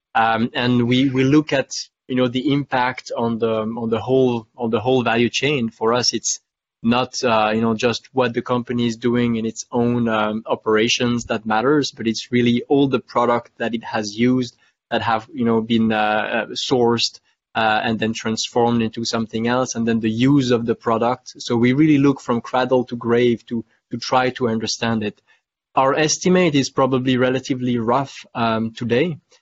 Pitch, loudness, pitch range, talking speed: 120 Hz, -19 LUFS, 115-130 Hz, 190 wpm